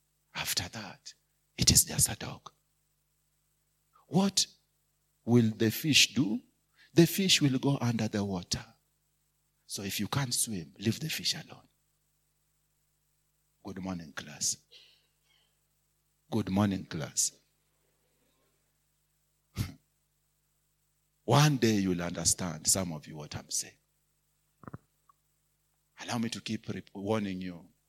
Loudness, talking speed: -29 LUFS, 110 wpm